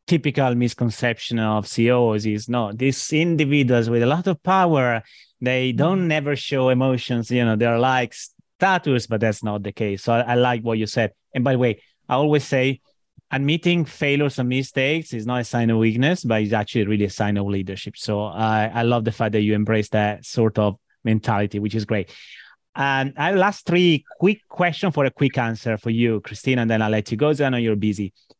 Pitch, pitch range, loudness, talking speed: 120 Hz, 110-140 Hz, -21 LUFS, 210 wpm